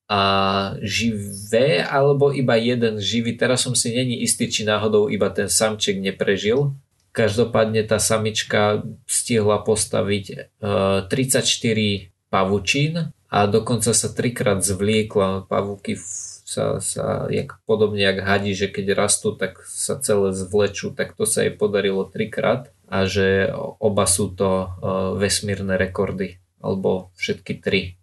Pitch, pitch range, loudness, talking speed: 105 Hz, 95-115 Hz, -21 LUFS, 125 wpm